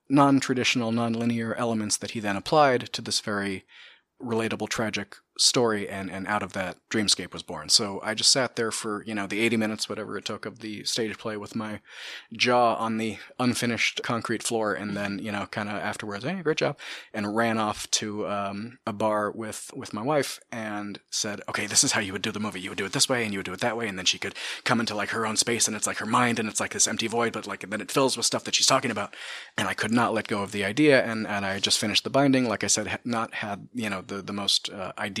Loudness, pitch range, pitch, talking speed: -26 LUFS, 100-115 Hz, 110 Hz, 265 wpm